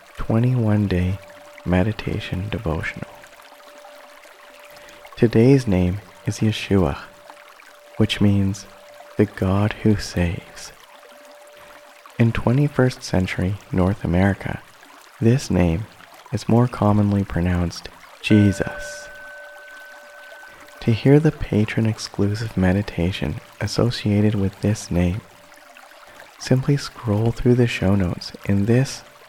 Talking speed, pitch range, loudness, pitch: 90 wpm, 95-120 Hz, -21 LUFS, 105 Hz